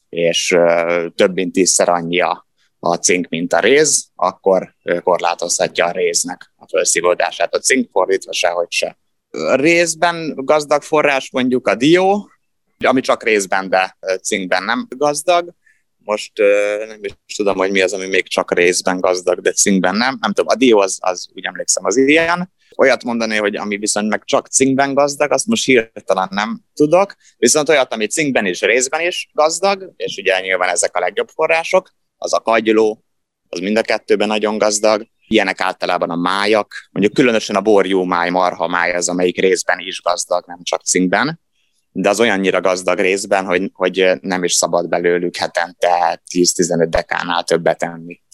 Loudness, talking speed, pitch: -16 LUFS, 165 wpm, 105 Hz